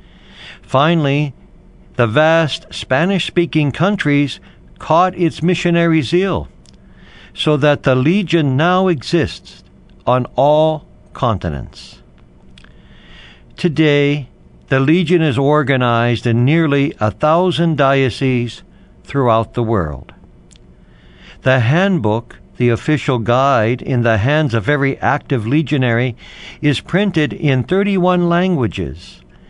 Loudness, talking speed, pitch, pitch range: -15 LUFS, 100 wpm, 140 Hz, 115-165 Hz